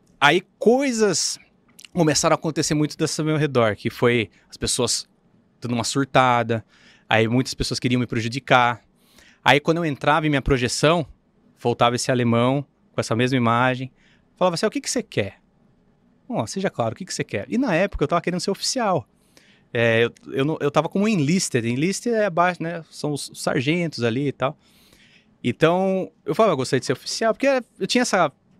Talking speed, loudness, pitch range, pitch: 190 wpm, -21 LUFS, 125-185 Hz, 150 Hz